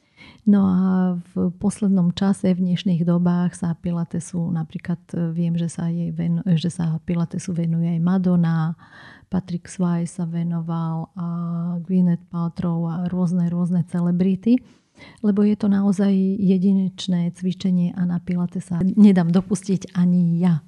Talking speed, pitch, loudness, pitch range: 130 wpm, 175 Hz, -21 LUFS, 170-185 Hz